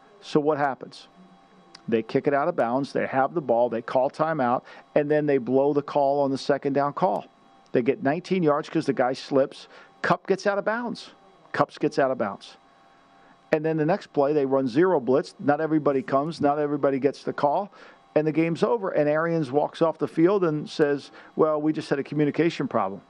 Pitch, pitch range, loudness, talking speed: 145 Hz, 135-155 Hz, -24 LUFS, 210 wpm